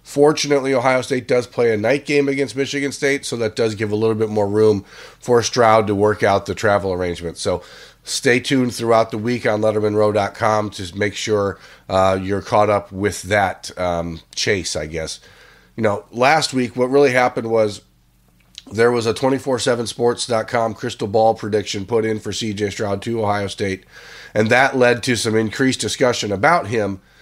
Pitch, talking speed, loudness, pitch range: 110 Hz, 180 wpm, -18 LUFS, 100-125 Hz